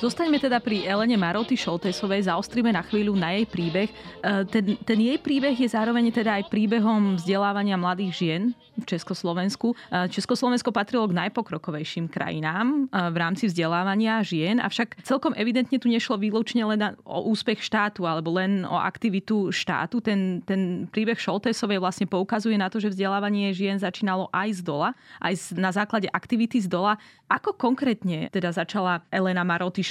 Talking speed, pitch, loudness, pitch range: 160 wpm, 205 Hz, -25 LUFS, 185-230 Hz